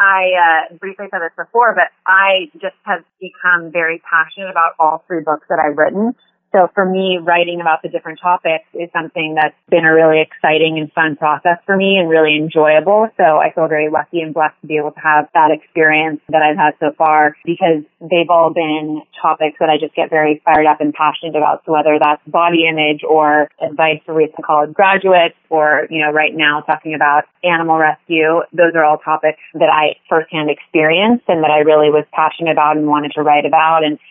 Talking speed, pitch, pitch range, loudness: 210 wpm, 160 Hz, 155-170 Hz, -13 LUFS